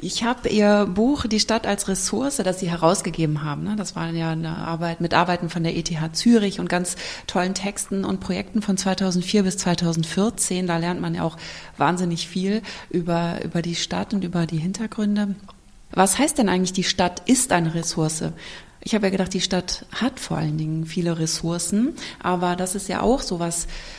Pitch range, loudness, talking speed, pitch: 170-205 Hz, -22 LUFS, 190 wpm, 185 Hz